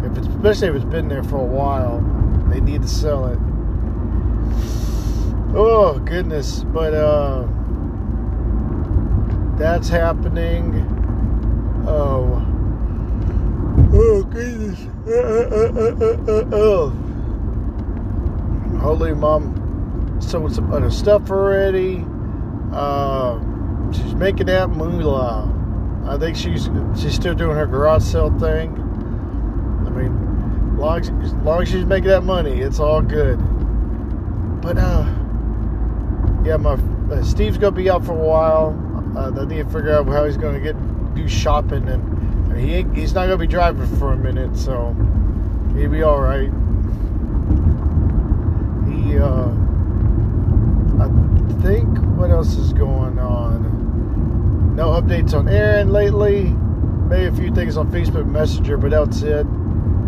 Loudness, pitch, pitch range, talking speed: -19 LUFS, 100 Hz, 85-110 Hz, 120 wpm